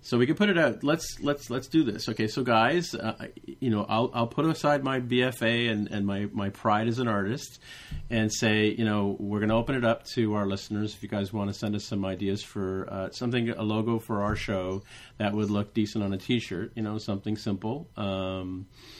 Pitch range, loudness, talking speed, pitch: 100-120 Hz, -28 LUFS, 230 wpm, 110 Hz